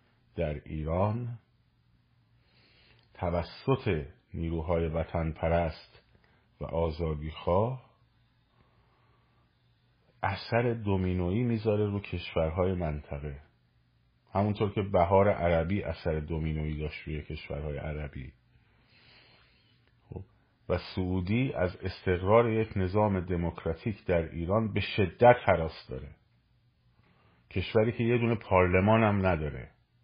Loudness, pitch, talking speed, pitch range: -30 LUFS, 95 Hz, 90 wpm, 80-115 Hz